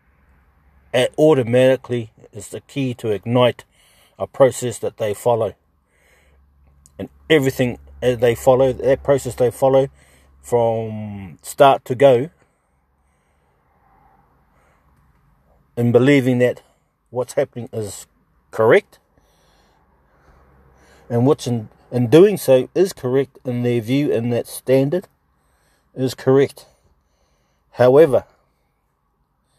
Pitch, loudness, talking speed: 115 Hz, -17 LUFS, 95 wpm